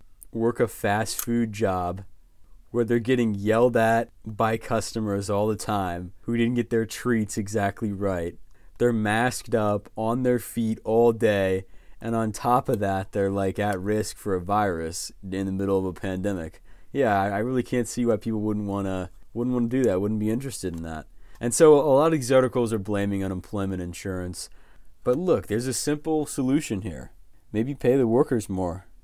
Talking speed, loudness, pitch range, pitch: 185 wpm, -25 LUFS, 95-120 Hz, 110 Hz